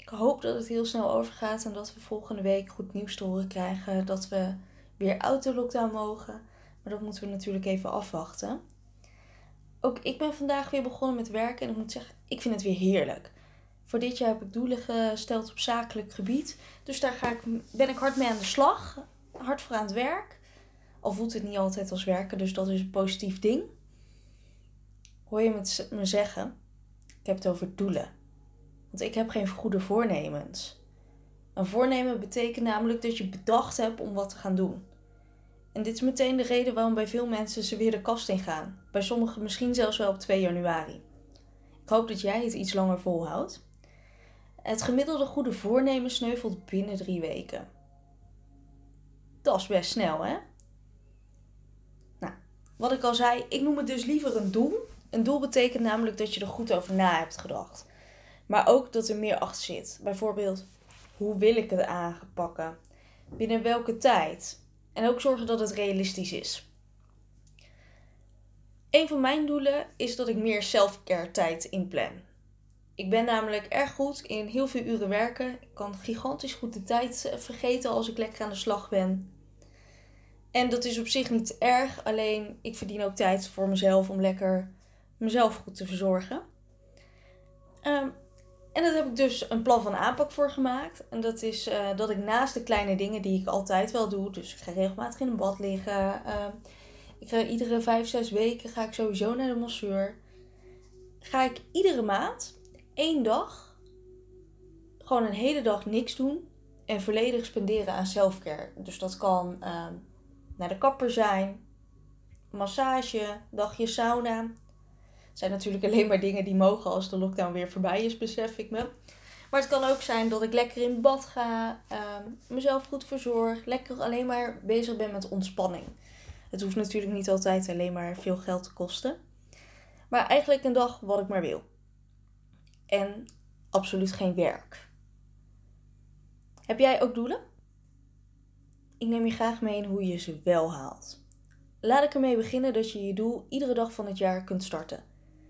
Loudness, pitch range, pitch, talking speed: -29 LUFS, 185-235 Hz, 210 Hz, 175 wpm